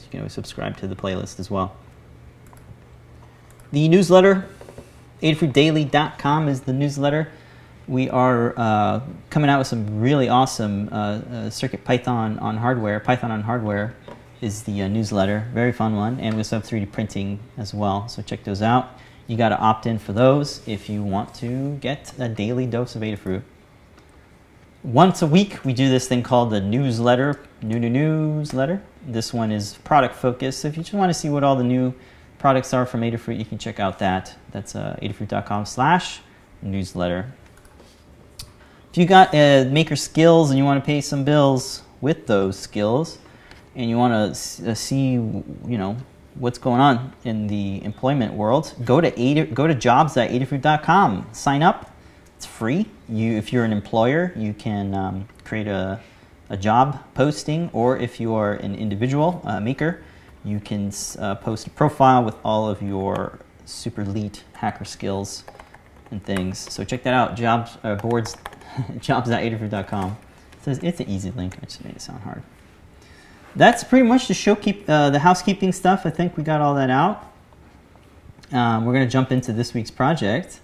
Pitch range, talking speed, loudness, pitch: 105-140 Hz, 170 wpm, -21 LUFS, 120 Hz